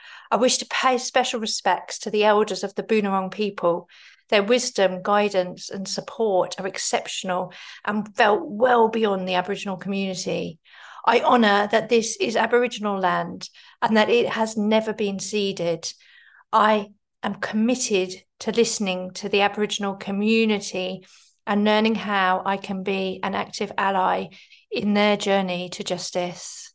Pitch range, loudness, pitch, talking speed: 190-220 Hz, -22 LUFS, 205 Hz, 145 wpm